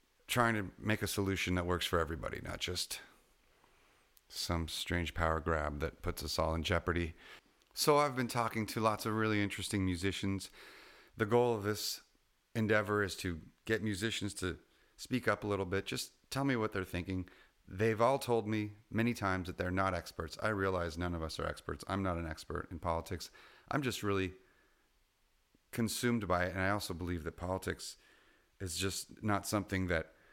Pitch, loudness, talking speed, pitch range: 95 Hz, -36 LUFS, 180 wpm, 90-110 Hz